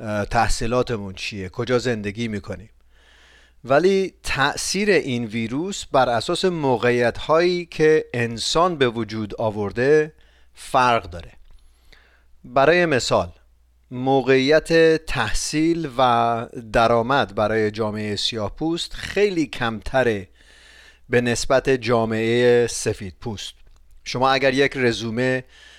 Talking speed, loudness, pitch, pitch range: 95 wpm, -20 LUFS, 120 Hz, 105-135 Hz